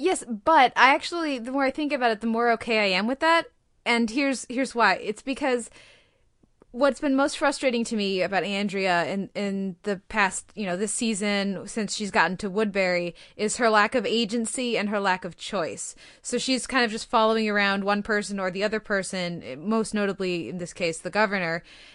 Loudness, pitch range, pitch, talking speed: -25 LUFS, 195-250 Hz, 220 Hz, 200 wpm